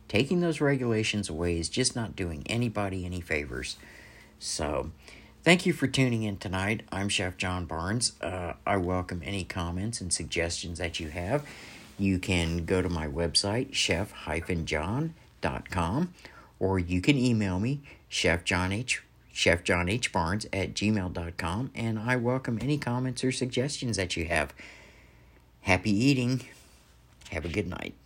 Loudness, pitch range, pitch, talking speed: -29 LUFS, 85-120 Hz, 95 Hz, 135 wpm